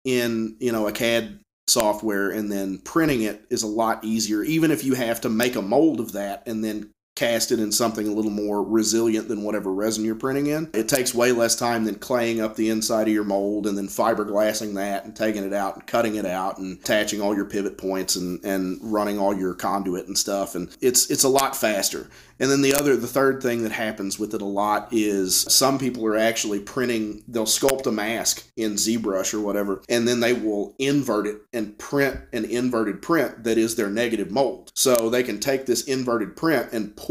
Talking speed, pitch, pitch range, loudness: 220 wpm, 110 Hz, 100-120 Hz, -23 LUFS